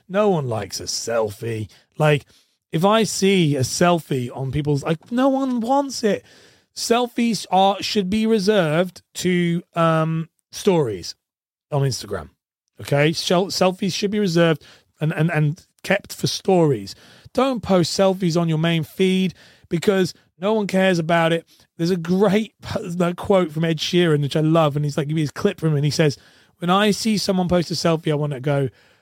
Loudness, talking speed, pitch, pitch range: -20 LUFS, 175 wpm, 170 Hz, 150-195 Hz